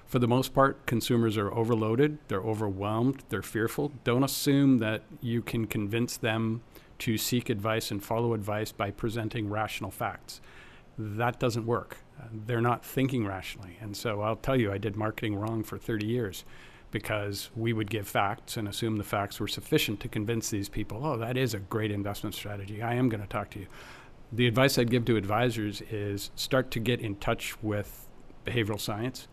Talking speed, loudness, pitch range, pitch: 185 wpm, -30 LUFS, 105-125 Hz, 115 Hz